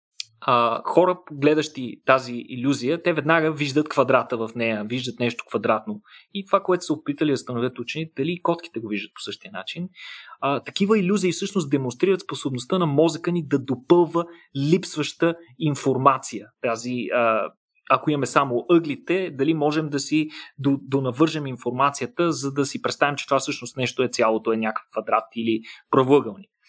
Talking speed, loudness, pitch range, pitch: 150 wpm, -23 LUFS, 125-165 Hz, 145 Hz